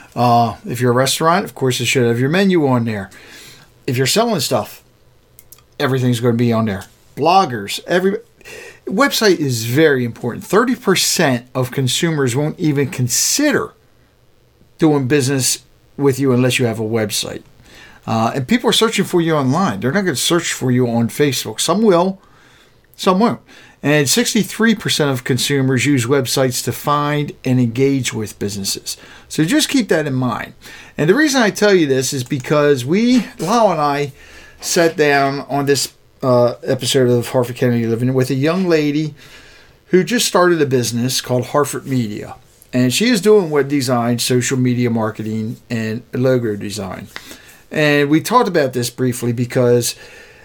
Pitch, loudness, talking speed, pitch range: 135 Hz, -16 LUFS, 165 wpm, 125-160 Hz